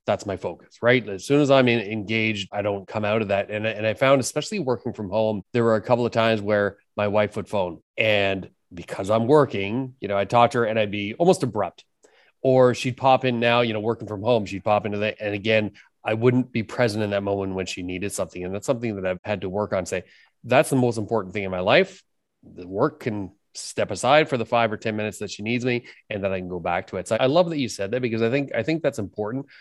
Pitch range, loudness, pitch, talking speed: 100-125 Hz, -23 LUFS, 110 Hz, 270 wpm